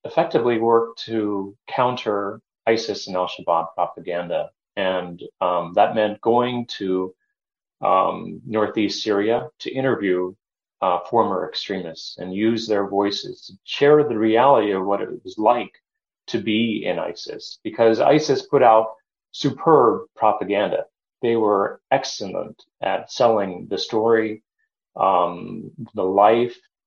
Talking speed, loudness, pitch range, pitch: 125 wpm, -21 LUFS, 100-120 Hz, 110 Hz